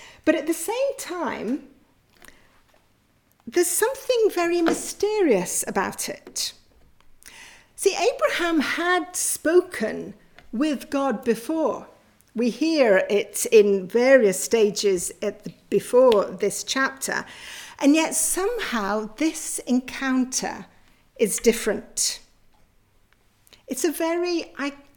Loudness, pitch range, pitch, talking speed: -23 LUFS, 215-345 Hz, 280 Hz, 95 wpm